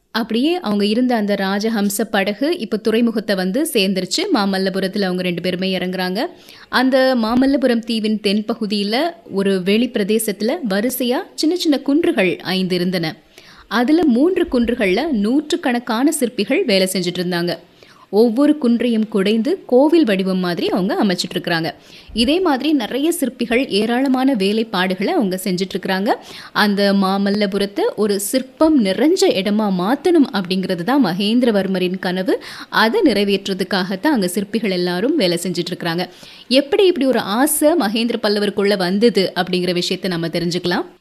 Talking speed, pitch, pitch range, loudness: 120 wpm, 210 Hz, 190-260 Hz, -17 LUFS